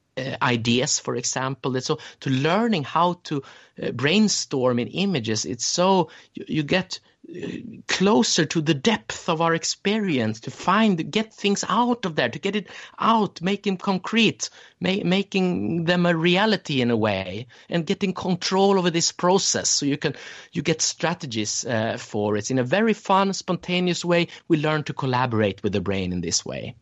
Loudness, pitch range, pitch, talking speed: -23 LUFS, 130-190 Hz, 165 Hz, 175 wpm